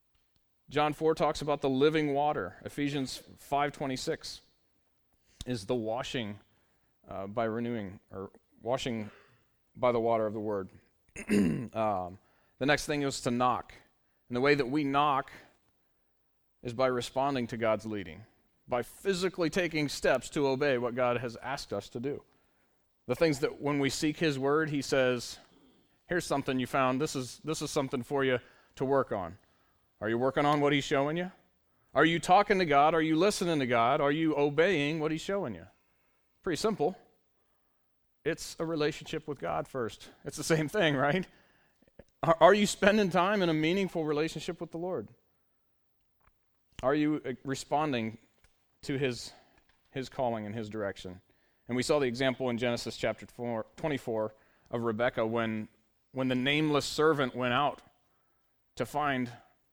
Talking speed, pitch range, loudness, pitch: 160 wpm, 115-150 Hz, -31 LUFS, 135 Hz